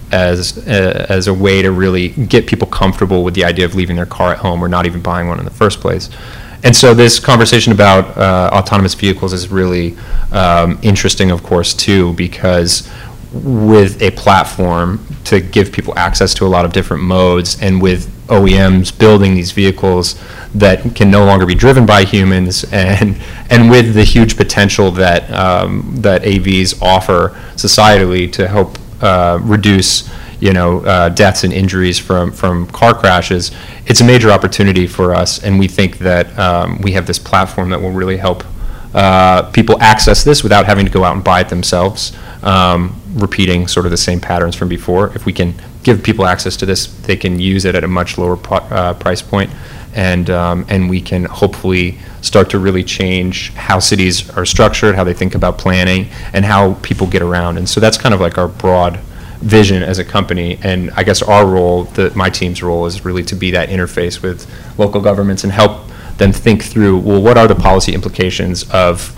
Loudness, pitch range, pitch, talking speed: -11 LUFS, 90-105 Hz, 95 Hz, 195 wpm